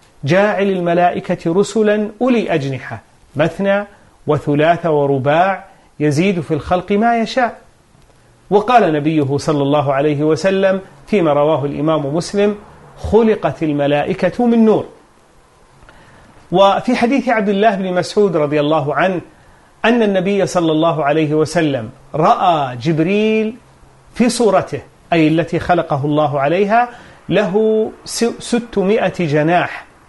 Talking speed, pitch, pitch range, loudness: 110 wpm, 180 Hz, 150-210 Hz, -15 LUFS